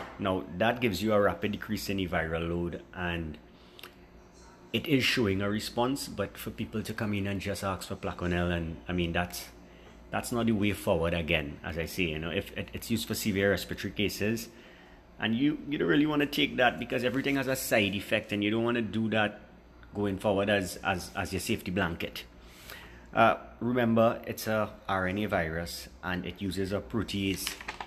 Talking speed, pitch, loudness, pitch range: 200 wpm, 100 Hz, -30 LUFS, 90-110 Hz